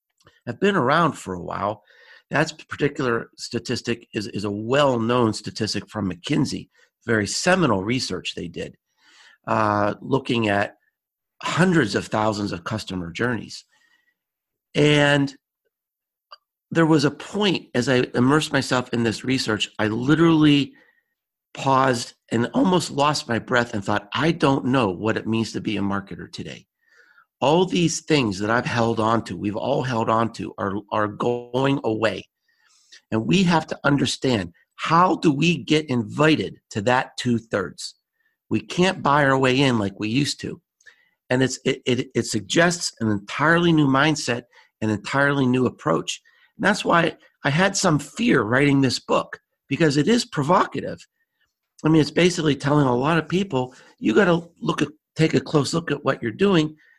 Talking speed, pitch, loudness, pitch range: 165 wpm, 130 Hz, -21 LUFS, 110-155 Hz